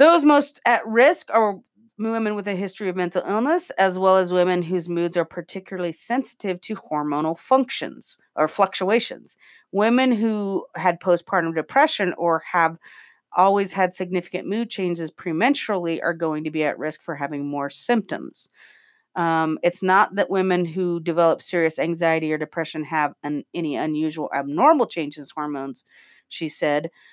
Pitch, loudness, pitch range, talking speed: 180 Hz, -22 LUFS, 160-210 Hz, 155 wpm